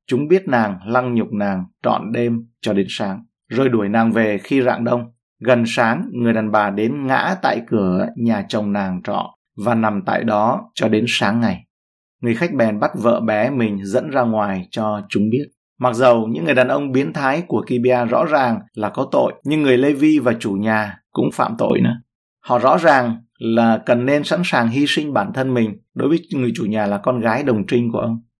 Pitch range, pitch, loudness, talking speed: 105-125 Hz, 115 Hz, -18 LUFS, 220 wpm